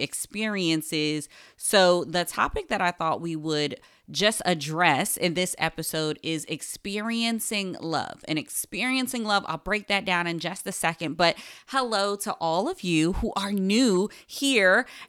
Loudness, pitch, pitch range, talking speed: -25 LUFS, 180 Hz, 160-205 Hz, 150 wpm